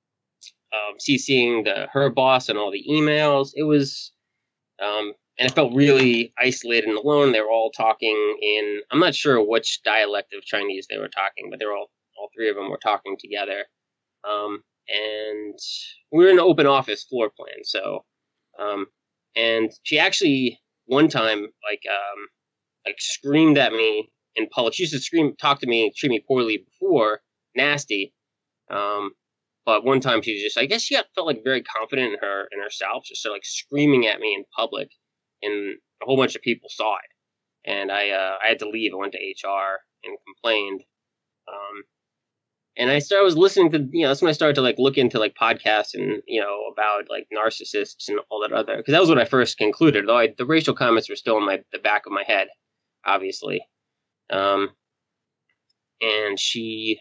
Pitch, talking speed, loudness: 135 Hz, 190 wpm, -21 LUFS